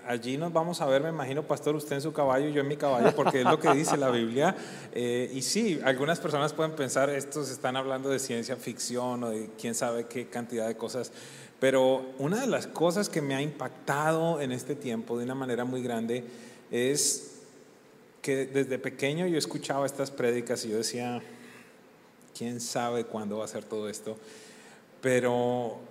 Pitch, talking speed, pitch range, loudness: 130 Hz, 190 wpm, 120-145 Hz, -30 LUFS